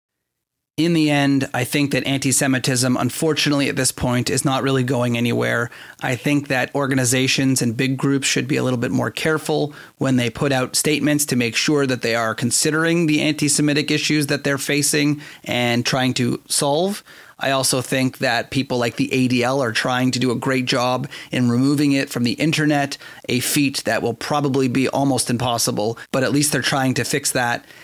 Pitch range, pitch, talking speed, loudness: 125-145 Hz, 135 Hz, 195 wpm, -19 LUFS